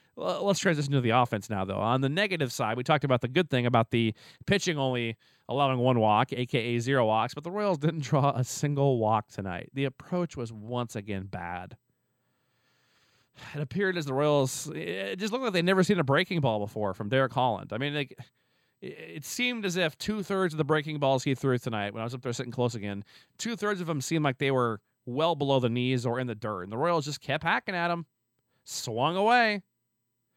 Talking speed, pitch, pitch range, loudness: 215 wpm, 135 Hz, 120-160 Hz, -28 LUFS